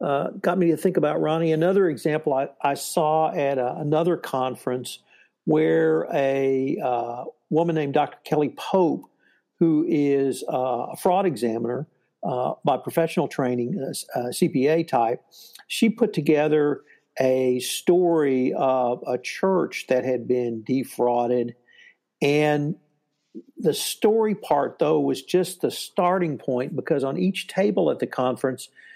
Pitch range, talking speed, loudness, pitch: 130-165 Hz, 140 wpm, -23 LUFS, 145 Hz